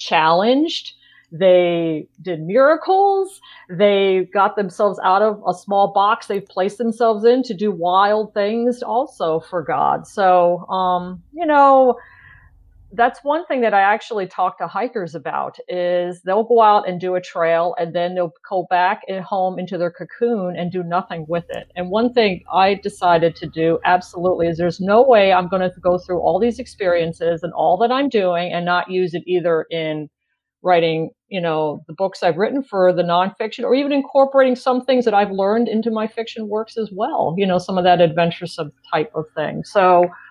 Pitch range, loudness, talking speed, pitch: 175-225 Hz, -18 LUFS, 185 wpm, 185 Hz